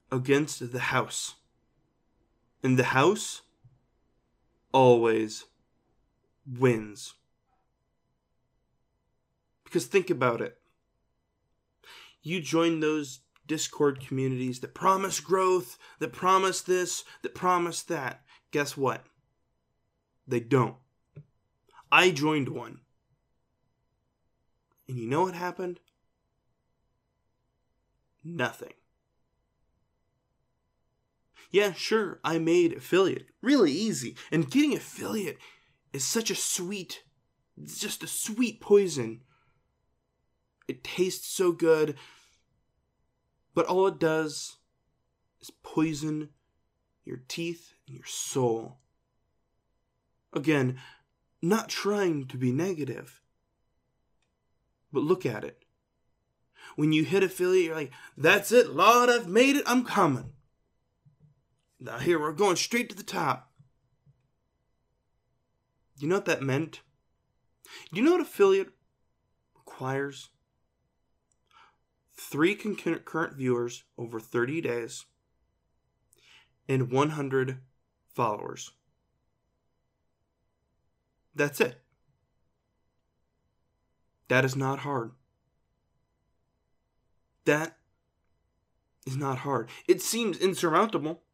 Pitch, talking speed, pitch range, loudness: 140 Hz, 90 wpm, 120-180 Hz, -27 LUFS